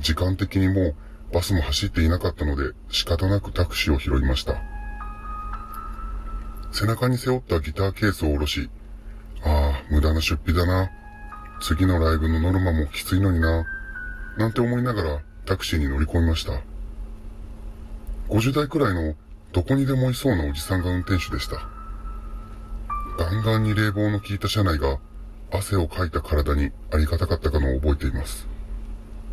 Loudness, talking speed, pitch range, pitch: -24 LUFS, 320 characters per minute, 75-105 Hz, 85 Hz